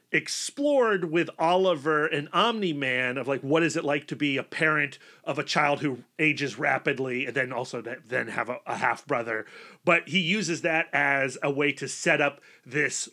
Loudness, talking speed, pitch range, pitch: -26 LUFS, 185 wpm, 135-165 Hz, 145 Hz